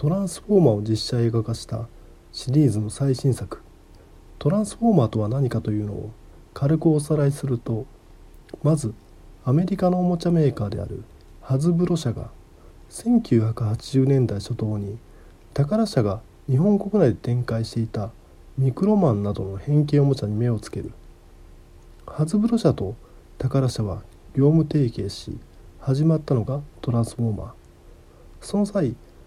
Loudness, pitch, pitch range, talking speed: -23 LUFS, 115 Hz, 100-145 Hz, 310 characters per minute